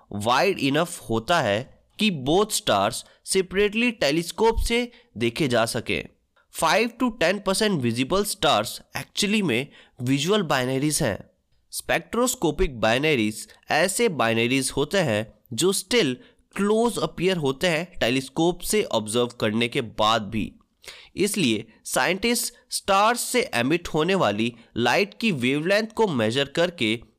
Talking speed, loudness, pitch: 125 wpm, -23 LUFS, 170 Hz